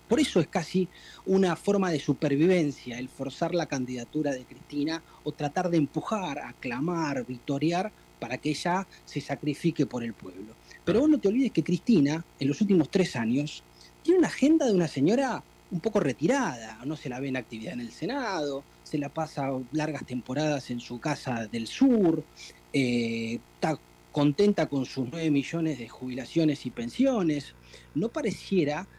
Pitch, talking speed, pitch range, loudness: 150 Hz, 170 wpm, 130-175 Hz, -28 LUFS